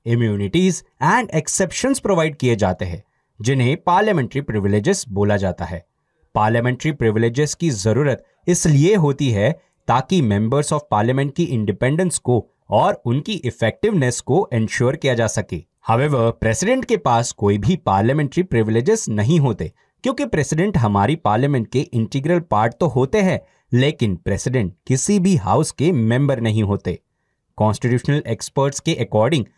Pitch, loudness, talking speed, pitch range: 125 Hz, -19 LUFS, 135 wpm, 110-155 Hz